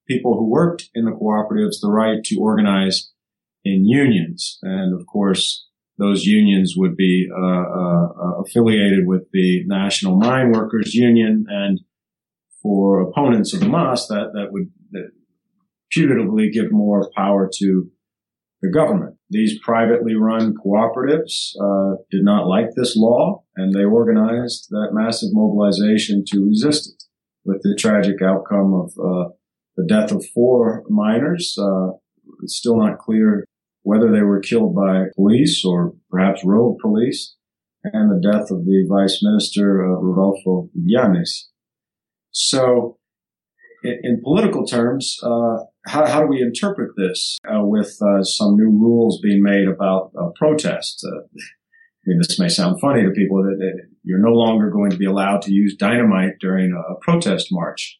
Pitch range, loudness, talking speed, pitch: 95-135 Hz, -17 LUFS, 155 wpm, 105 Hz